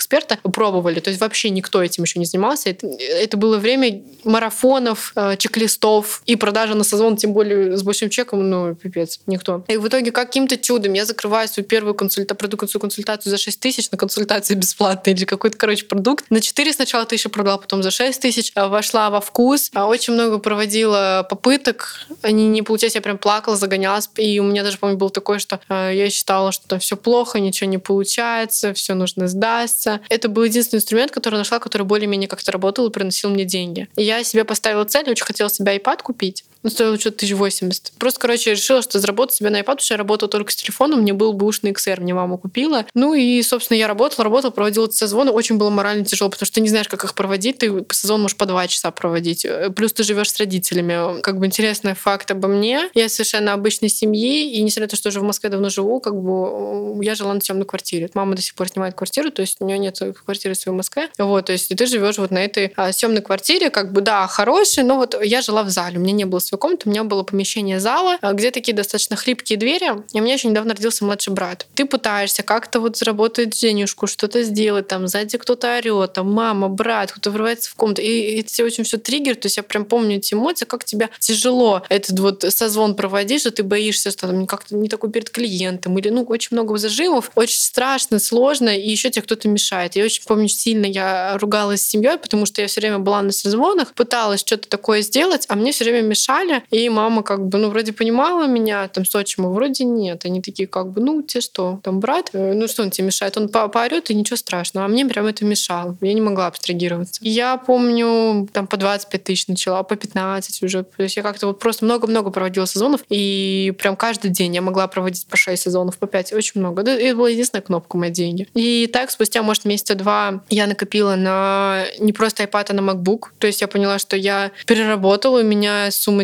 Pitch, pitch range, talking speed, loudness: 210 Hz, 195-230 Hz, 220 wpm, -18 LUFS